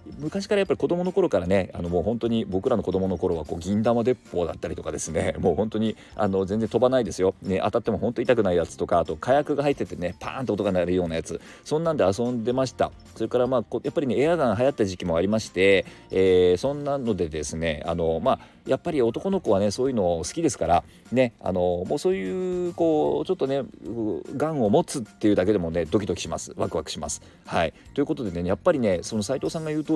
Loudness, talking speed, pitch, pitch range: -25 LUFS, 485 characters per minute, 110 Hz, 90-130 Hz